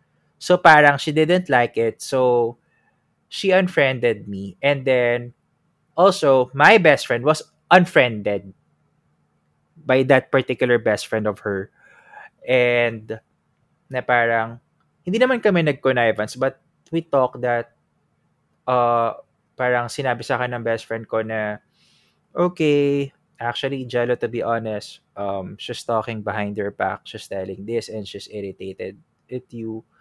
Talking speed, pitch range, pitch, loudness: 130 wpm, 110-140 Hz, 120 Hz, -19 LUFS